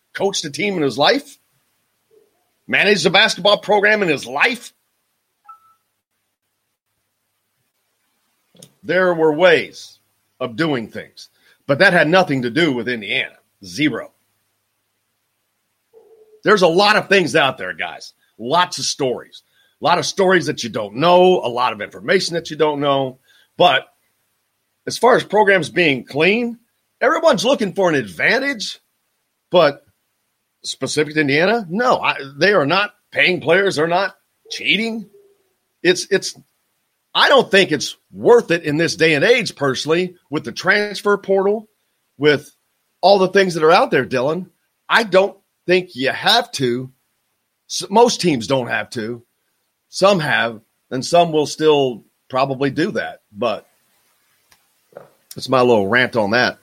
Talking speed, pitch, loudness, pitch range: 145 wpm, 165 Hz, -16 LUFS, 130-200 Hz